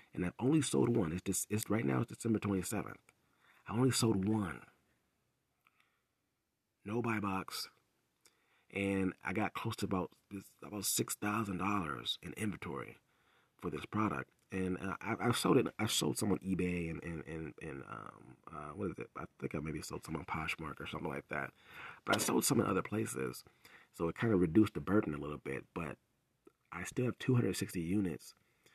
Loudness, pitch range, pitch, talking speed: -37 LUFS, 90-110 Hz, 95 Hz, 195 wpm